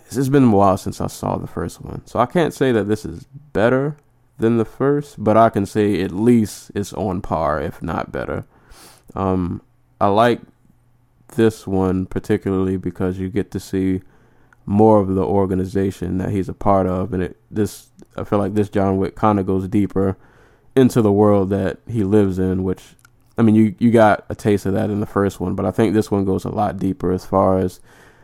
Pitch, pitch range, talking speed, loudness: 100 Hz, 95-115 Hz, 210 wpm, -19 LUFS